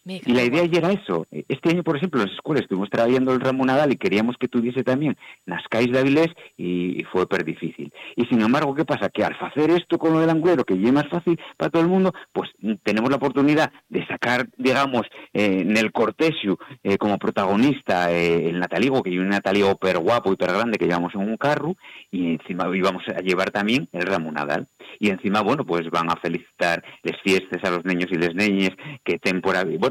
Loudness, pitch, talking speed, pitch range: -22 LUFS, 110 Hz, 225 wpm, 95-145 Hz